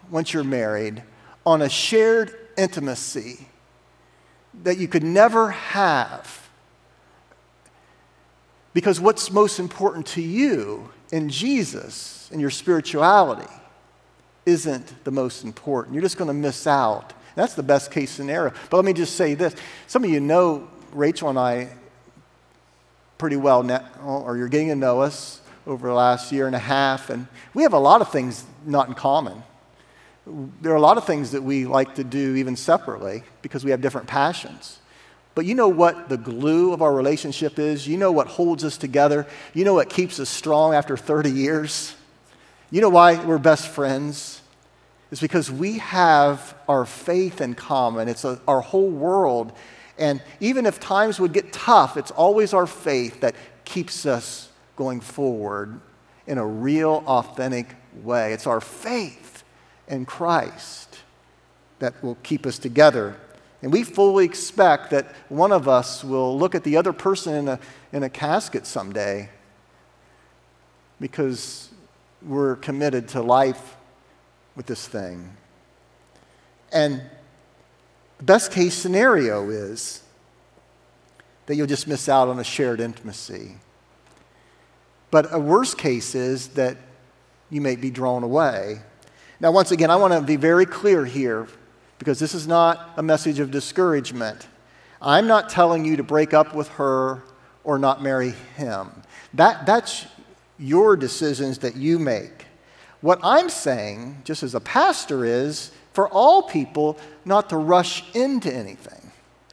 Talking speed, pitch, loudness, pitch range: 150 wpm, 140 Hz, -21 LUFS, 125-165 Hz